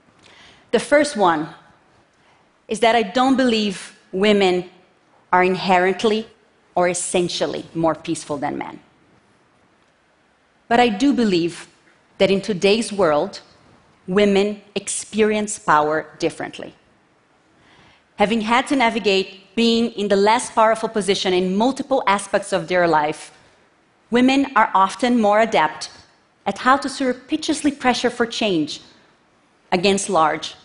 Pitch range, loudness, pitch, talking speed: 180-235 Hz, -19 LUFS, 205 Hz, 115 wpm